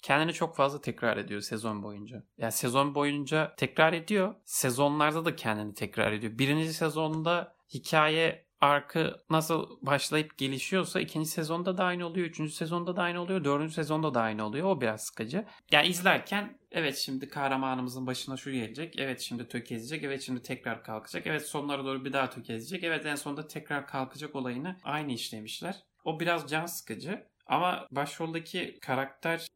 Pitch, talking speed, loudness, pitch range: 150 Hz, 160 wpm, -31 LUFS, 130-165 Hz